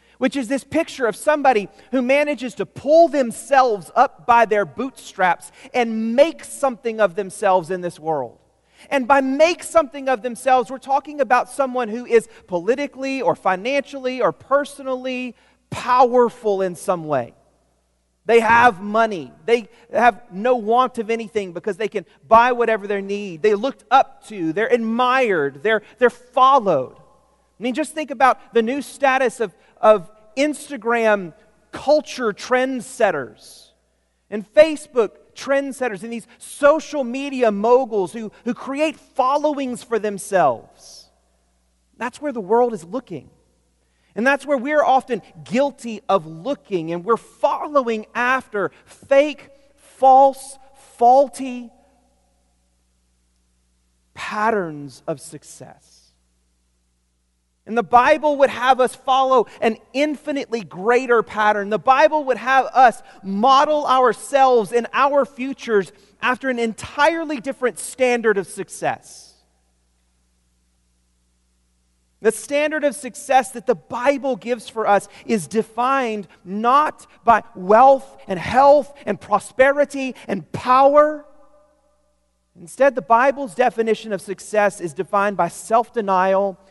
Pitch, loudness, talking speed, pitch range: 235 Hz, -19 LUFS, 125 wpm, 195-270 Hz